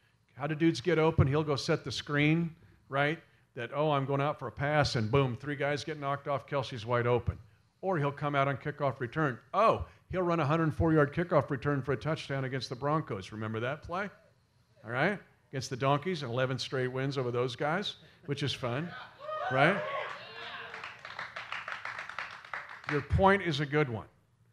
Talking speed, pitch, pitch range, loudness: 185 wpm, 140 Hz, 125-155 Hz, -32 LUFS